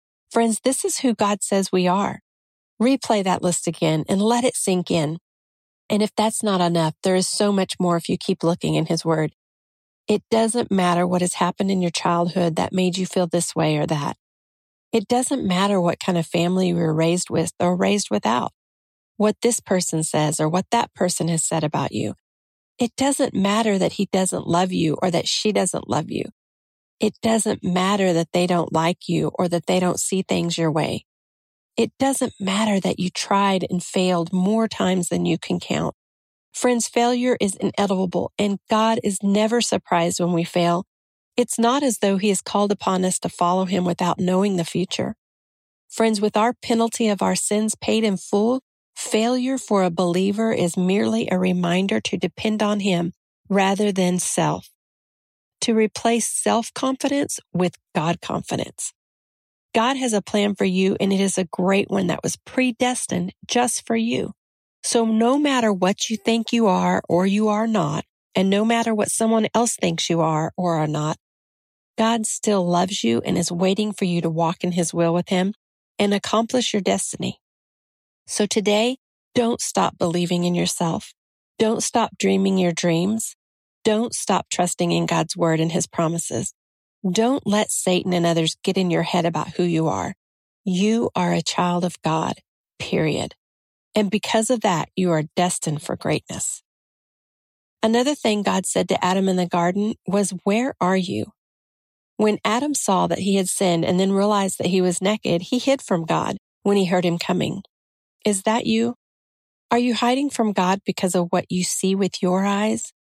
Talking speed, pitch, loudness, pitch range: 185 wpm, 190 Hz, -21 LUFS, 175-220 Hz